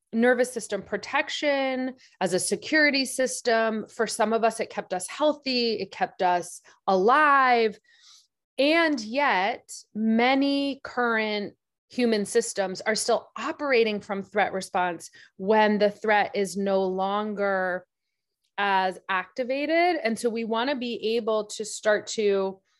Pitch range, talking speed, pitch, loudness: 200-255 Hz, 130 wpm, 220 Hz, -25 LUFS